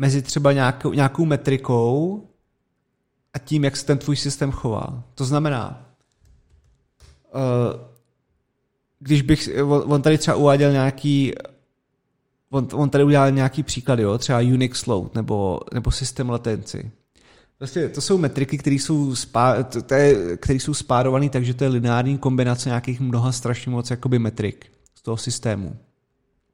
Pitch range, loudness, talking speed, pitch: 120-140 Hz, -21 LUFS, 135 wpm, 130 Hz